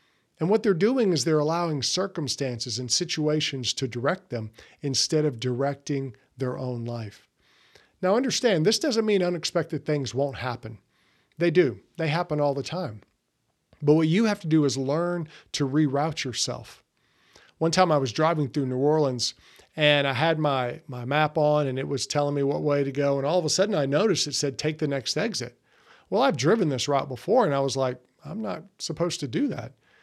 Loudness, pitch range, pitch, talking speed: -25 LUFS, 135-160 Hz, 145 Hz, 200 wpm